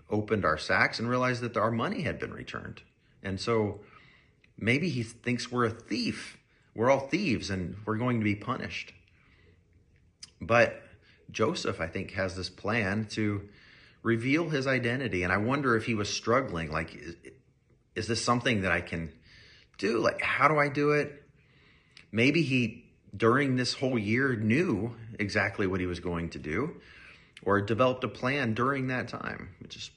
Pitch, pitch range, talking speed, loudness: 115 Hz, 100-125 Hz, 170 wpm, -29 LUFS